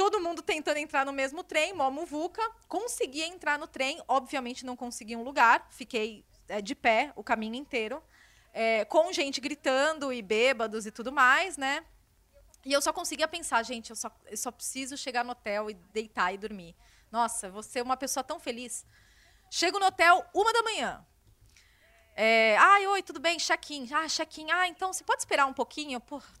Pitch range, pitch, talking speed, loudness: 235-325 Hz, 275 Hz, 185 wpm, -29 LUFS